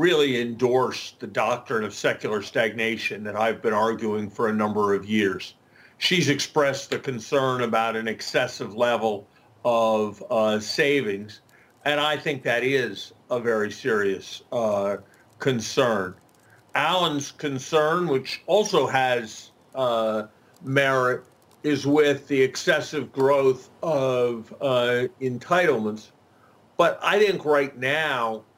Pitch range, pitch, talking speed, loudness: 110-140 Hz, 125 Hz, 120 wpm, -24 LUFS